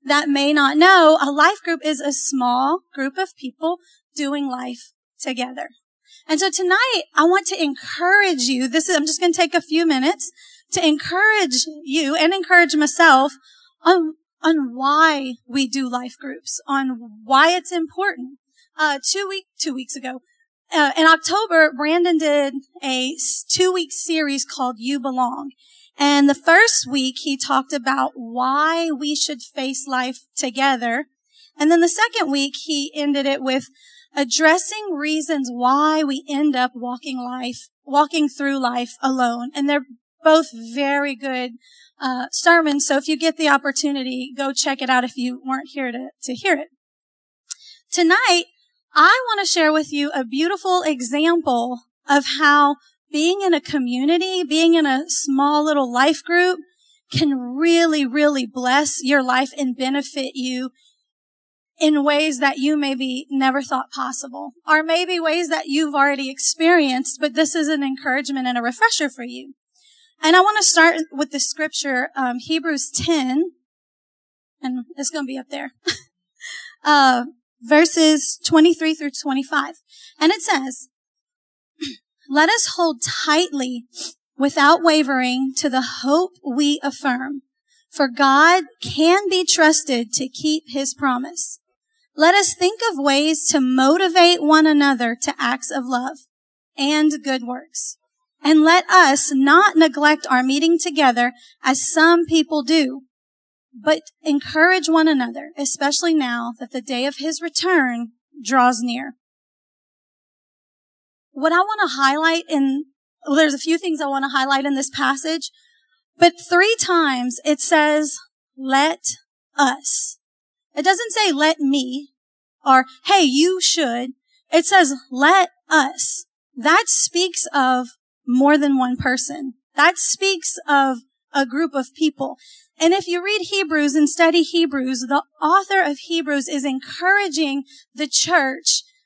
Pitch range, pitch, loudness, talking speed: 270-335 Hz, 295 Hz, -17 LUFS, 145 wpm